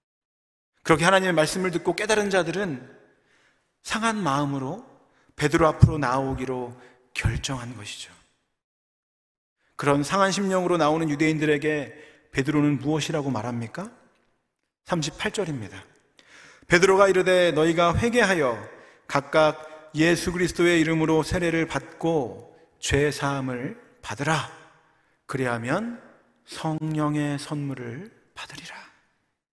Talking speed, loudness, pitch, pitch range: 260 characters per minute, -24 LUFS, 155 Hz, 135-175 Hz